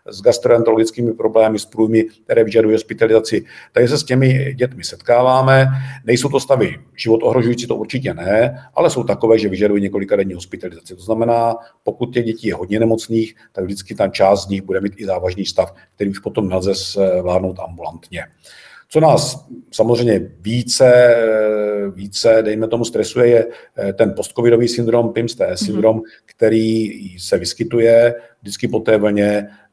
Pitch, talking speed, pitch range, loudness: 110 Hz, 145 wpm, 100-120 Hz, -16 LUFS